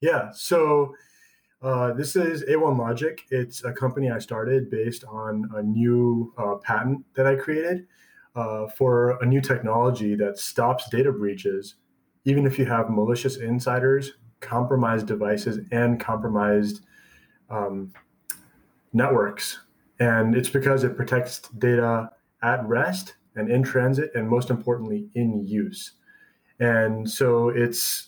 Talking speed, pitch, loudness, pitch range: 130 wpm, 120 Hz, -24 LUFS, 110-130 Hz